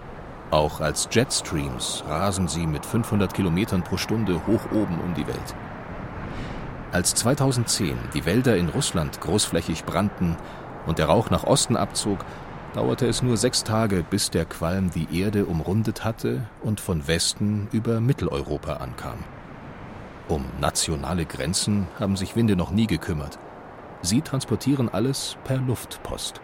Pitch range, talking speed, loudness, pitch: 90-115 Hz, 140 wpm, -24 LUFS, 105 Hz